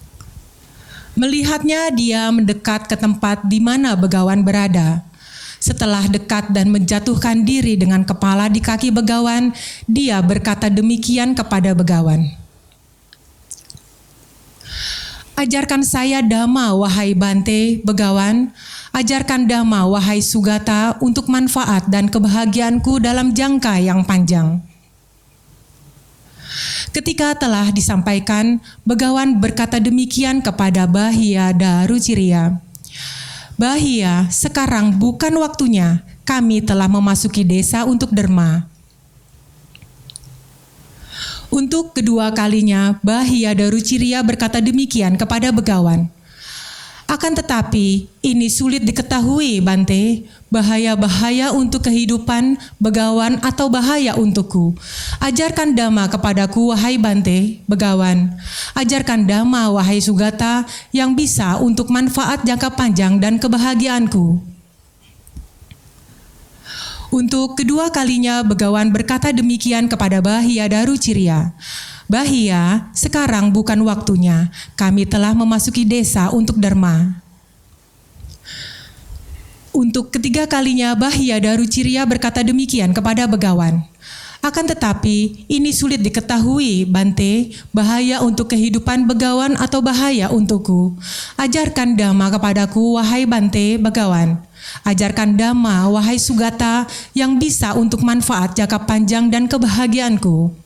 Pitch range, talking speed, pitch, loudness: 195-245 Hz, 95 wpm, 220 Hz, -15 LUFS